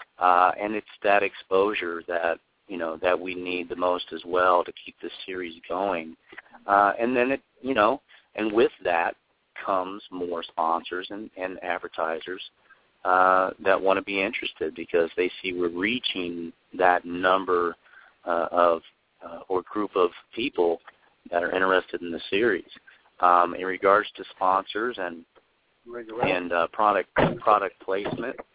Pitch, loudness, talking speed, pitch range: 90 Hz, -25 LUFS, 150 wpm, 85-95 Hz